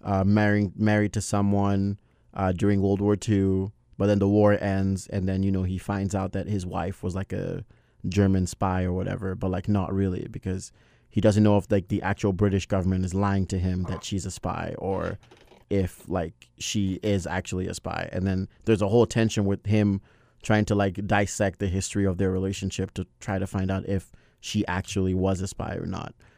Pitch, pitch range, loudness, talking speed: 100 Hz, 95-105 Hz, -26 LUFS, 210 wpm